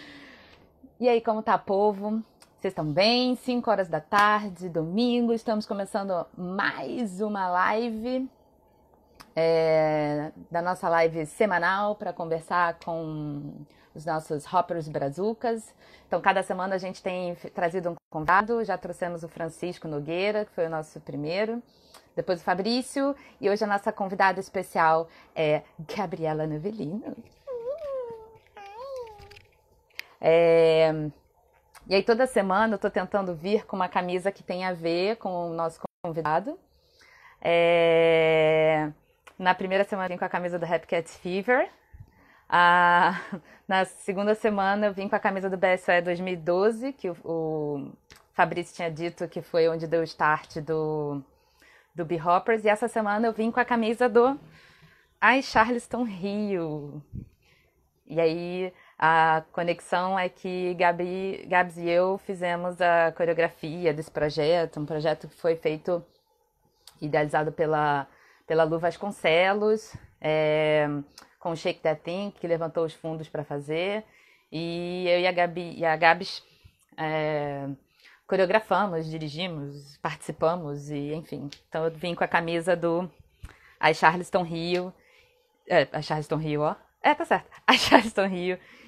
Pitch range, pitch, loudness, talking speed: 160-205 Hz, 180 Hz, -26 LUFS, 140 wpm